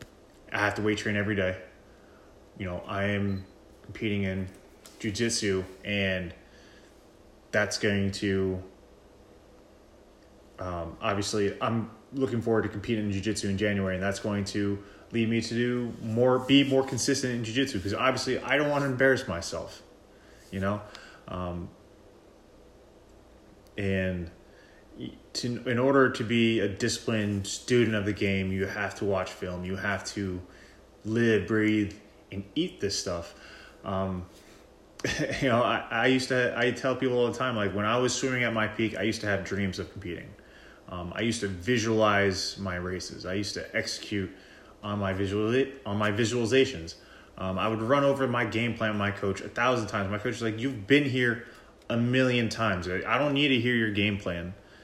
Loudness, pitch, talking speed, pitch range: -28 LUFS, 105 Hz, 170 wpm, 95-115 Hz